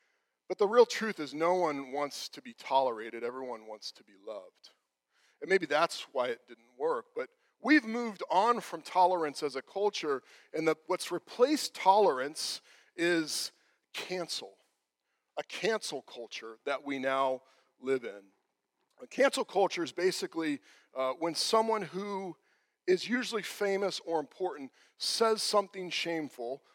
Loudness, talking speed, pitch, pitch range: -32 LUFS, 145 wpm, 185 Hz, 145-240 Hz